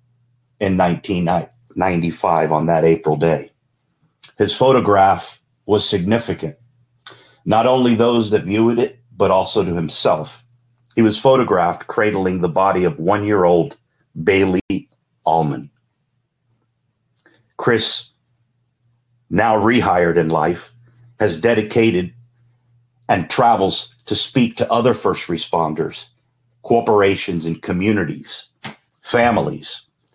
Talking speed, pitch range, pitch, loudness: 100 wpm, 90-120 Hz, 115 Hz, -17 LUFS